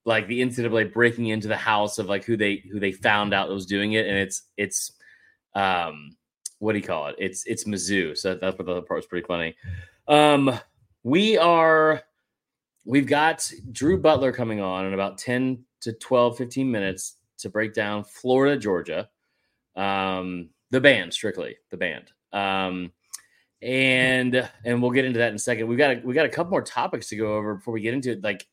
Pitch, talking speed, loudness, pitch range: 110 Hz, 205 wpm, -23 LUFS, 95-125 Hz